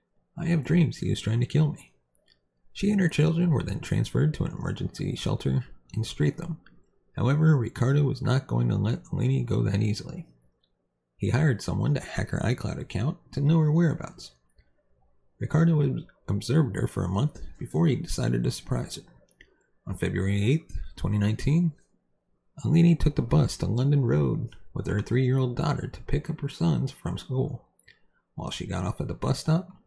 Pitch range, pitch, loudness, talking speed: 95-155 Hz, 130 Hz, -27 LUFS, 180 wpm